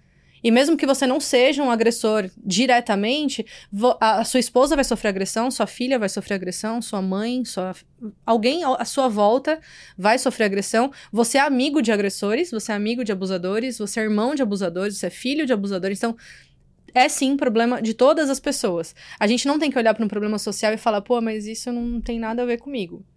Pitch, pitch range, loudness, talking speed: 230 Hz, 210-255 Hz, -21 LUFS, 205 wpm